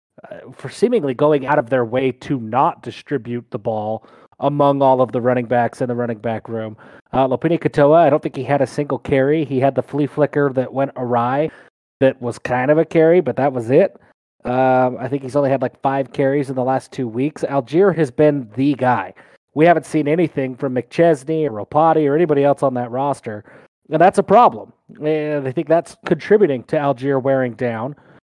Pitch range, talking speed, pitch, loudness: 125-150 Hz, 210 wpm, 135 Hz, -18 LUFS